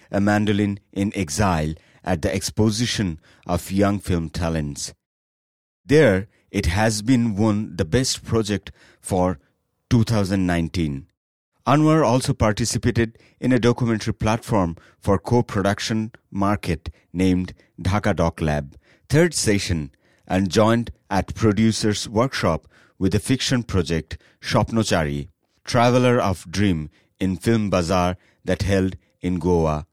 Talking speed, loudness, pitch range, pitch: 115 wpm, -21 LUFS, 90-110 Hz, 100 Hz